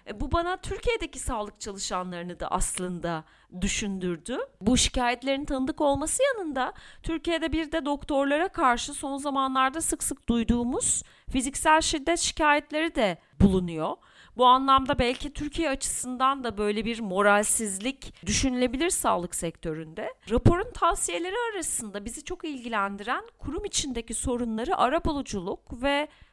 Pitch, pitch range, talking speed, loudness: 265 Hz, 220-310 Hz, 120 wpm, -27 LUFS